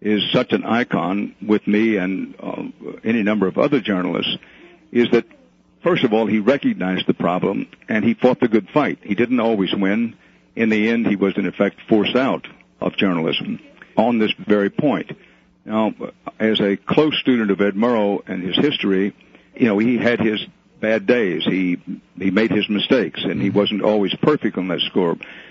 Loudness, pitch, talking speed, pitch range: -19 LUFS, 105 Hz, 185 wpm, 100-115 Hz